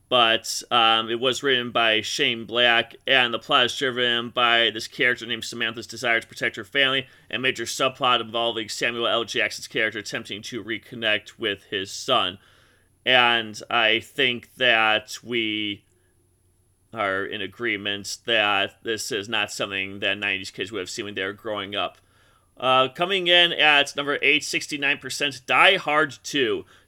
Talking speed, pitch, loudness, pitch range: 160 wpm, 115 Hz, -22 LUFS, 105-130 Hz